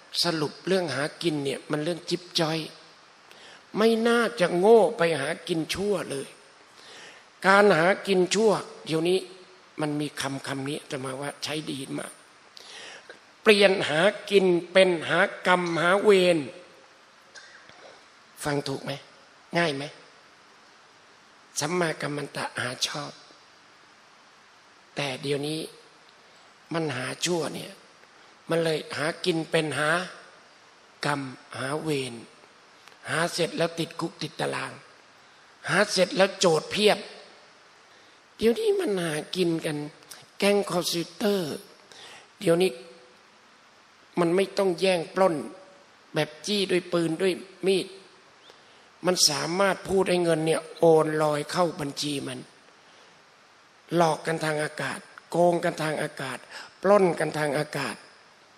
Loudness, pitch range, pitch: -25 LUFS, 150-190 Hz, 170 Hz